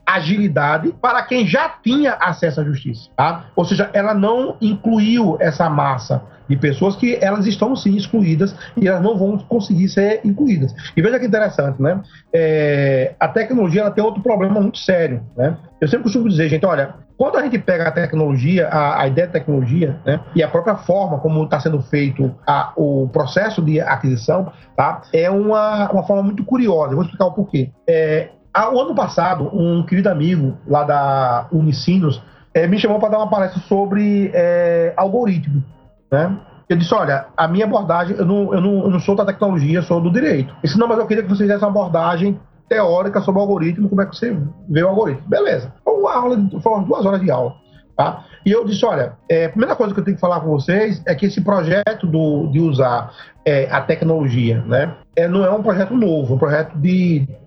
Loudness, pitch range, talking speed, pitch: -17 LUFS, 155-205 Hz, 205 wpm, 180 Hz